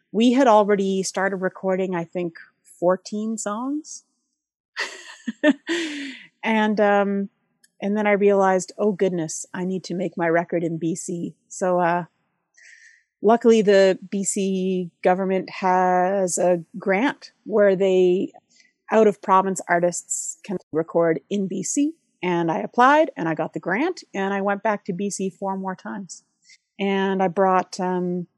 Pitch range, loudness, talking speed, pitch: 180-215 Hz, -22 LUFS, 135 wpm, 195 Hz